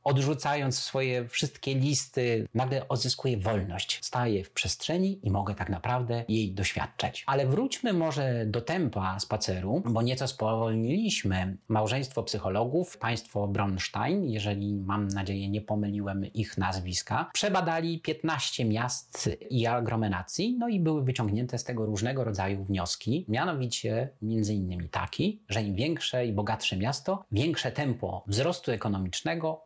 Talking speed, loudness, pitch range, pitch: 130 wpm, -30 LUFS, 100-140 Hz, 115 Hz